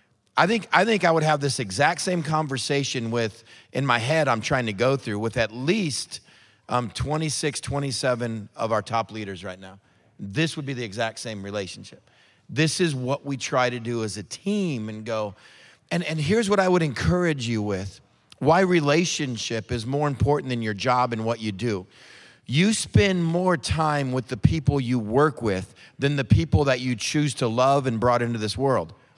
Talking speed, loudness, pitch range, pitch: 195 wpm, -24 LUFS, 115-150 Hz, 130 Hz